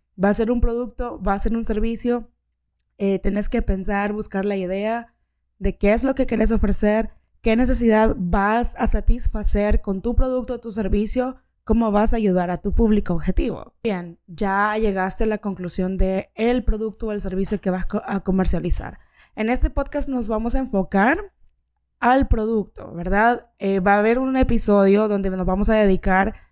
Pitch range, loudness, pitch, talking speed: 195-230 Hz, -21 LUFS, 210 Hz, 180 wpm